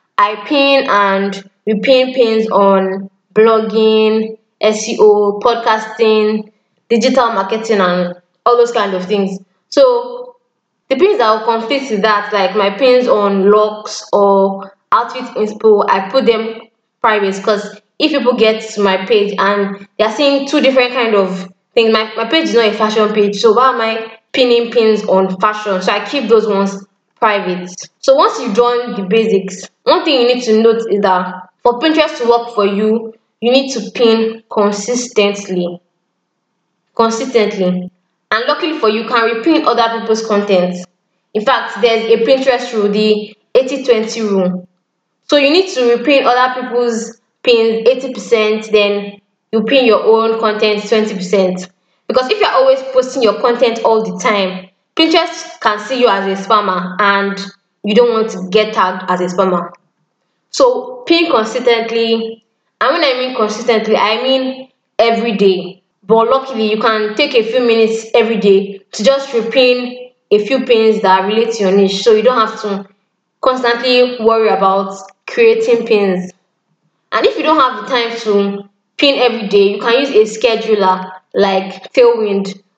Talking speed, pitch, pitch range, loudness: 160 wpm, 220 Hz, 200-240 Hz, -13 LUFS